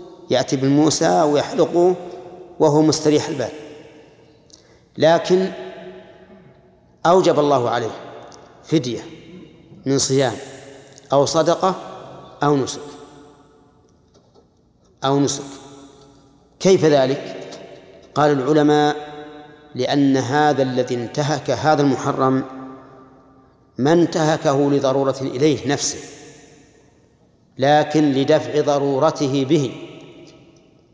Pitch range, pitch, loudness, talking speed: 135-150 Hz, 145 Hz, -18 LUFS, 75 wpm